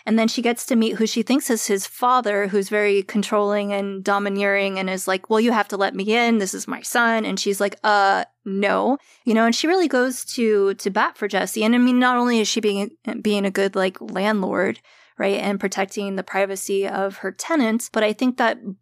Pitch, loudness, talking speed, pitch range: 210 Hz, -21 LUFS, 230 wpm, 200-230 Hz